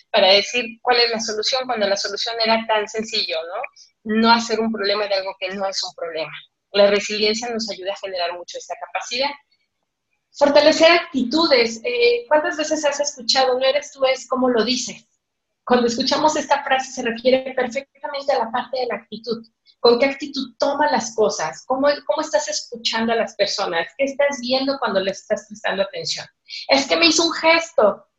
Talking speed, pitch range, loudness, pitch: 185 wpm, 210-285 Hz, -19 LUFS, 245 Hz